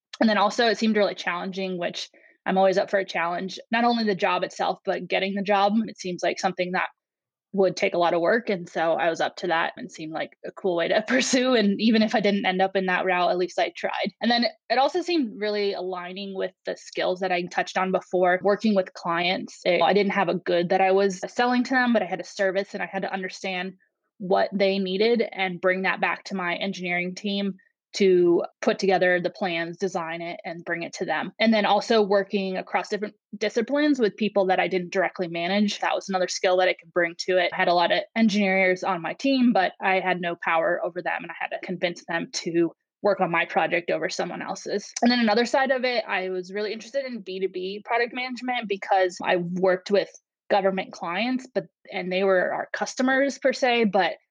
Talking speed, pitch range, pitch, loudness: 230 wpm, 185-215 Hz, 195 Hz, -24 LUFS